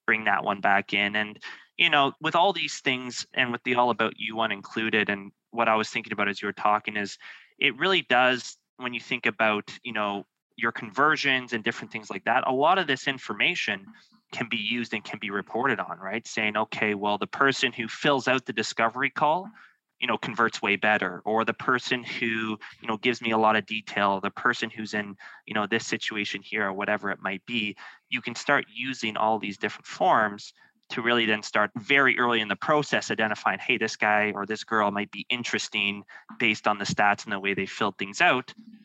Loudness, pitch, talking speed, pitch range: -26 LUFS, 110 Hz, 220 wpm, 105-125 Hz